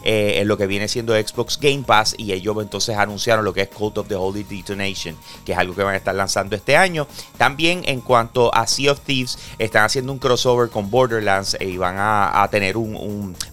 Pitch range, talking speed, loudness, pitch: 100-120 Hz, 230 wpm, -19 LUFS, 105 Hz